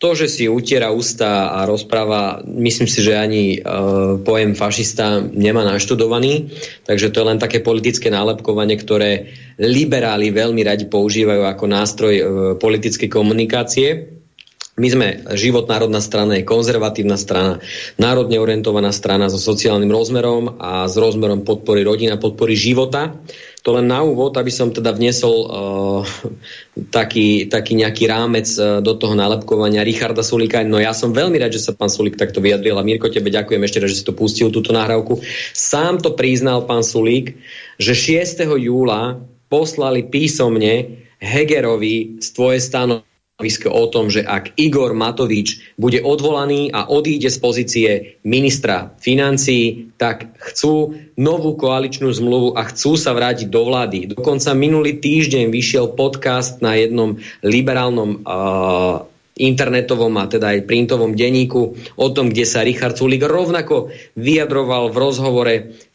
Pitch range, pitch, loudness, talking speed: 105-130 Hz, 115 Hz, -16 LUFS, 145 wpm